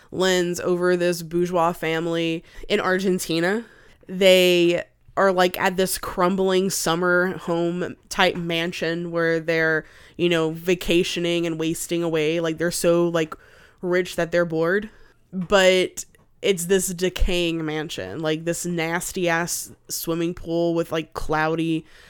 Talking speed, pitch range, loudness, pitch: 130 wpm, 165-185 Hz, -22 LUFS, 170 Hz